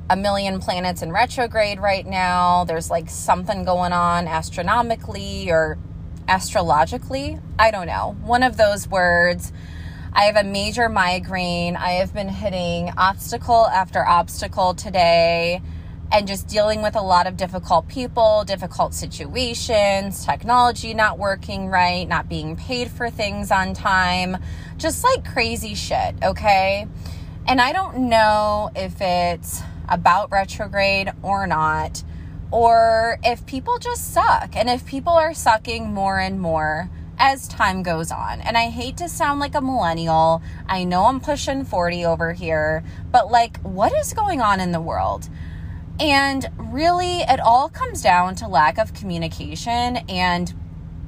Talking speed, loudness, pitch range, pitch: 145 wpm, -20 LUFS, 165-230 Hz, 190 Hz